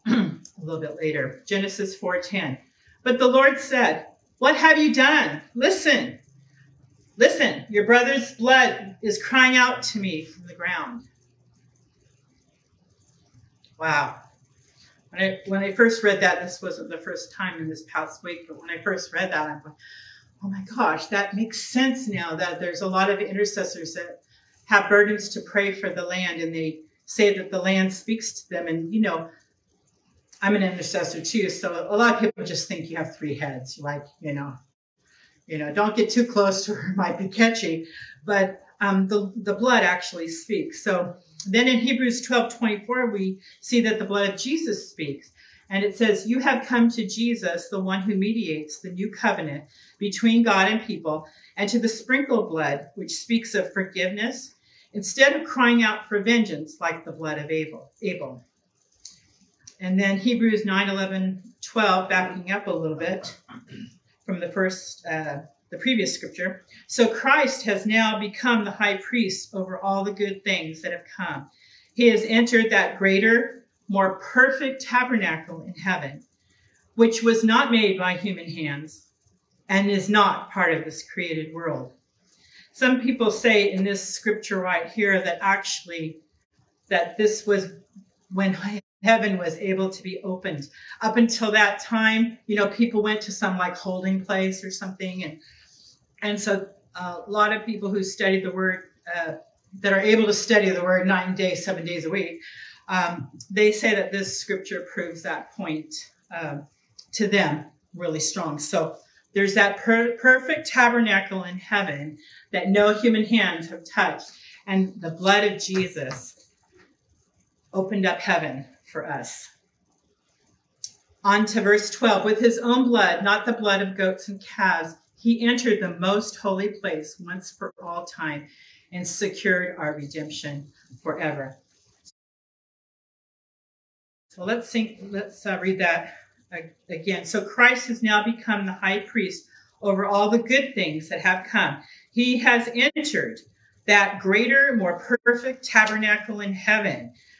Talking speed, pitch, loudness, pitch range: 160 wpm, 195 Hz, -23 LUFS, 175-220 Hz